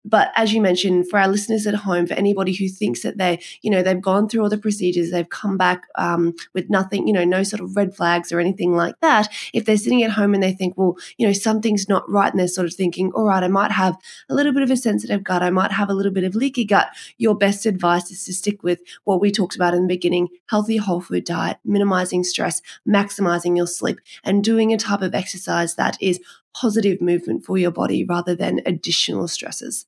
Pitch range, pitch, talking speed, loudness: 180-210 Hz, 190 Hz, 240 wpm, -20 LUFS